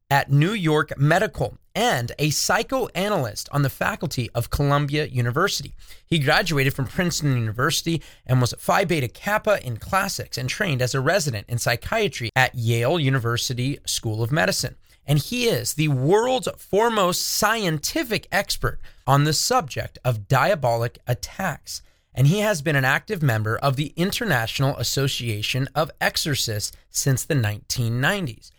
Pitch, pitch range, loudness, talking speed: 140 Hz, 120-165 Hz, -22 LUFS, 145 wpm